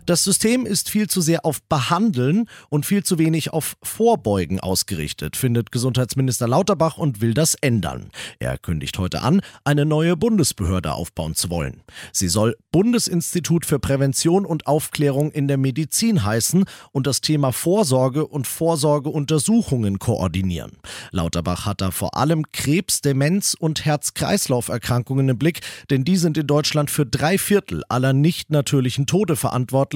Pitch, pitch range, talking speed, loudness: 145 Hz, 120-165 Hz, 150 wpm, -20 LUFS